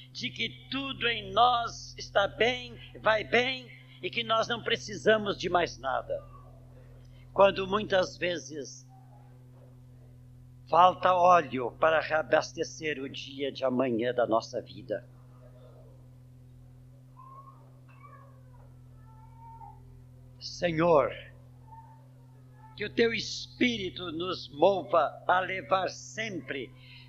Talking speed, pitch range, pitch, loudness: 90 wpm, 125-160 Hz, 130 Hz, -28 LUFS